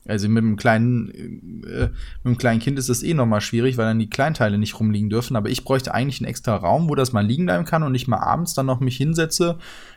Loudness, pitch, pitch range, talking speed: -21 LUFS, 120 Hz, 110-135 Hz, 260 wpm